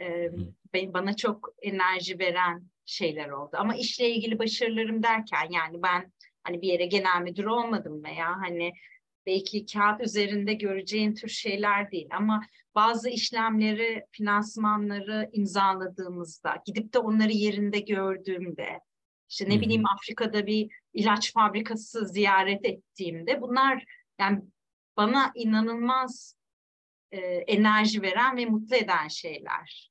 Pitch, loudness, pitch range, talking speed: 205 Hz, -27 LUFS, 185-220 Hz, 120 wpm